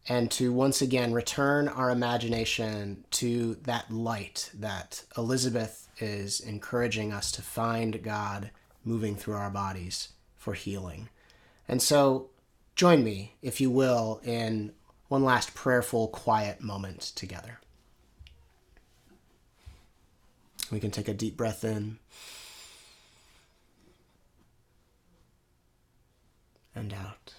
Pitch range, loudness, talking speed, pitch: 100-120 Hz, -30 LUFS, 105 wpm, 110 Hz